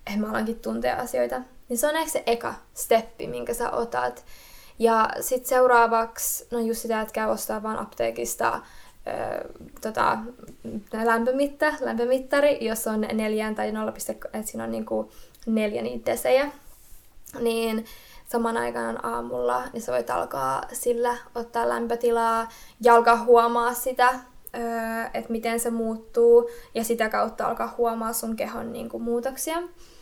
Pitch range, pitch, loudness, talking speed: 215-245 Hz, 230 Hz, -25 LUFS, 140 wpm